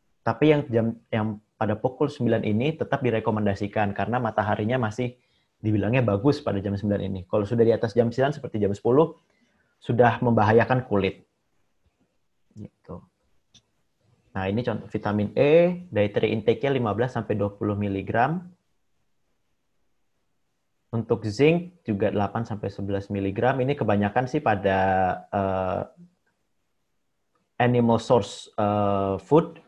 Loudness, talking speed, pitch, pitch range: -24 LUFS, 120 wpm, 110 Hz, 100-125 Hz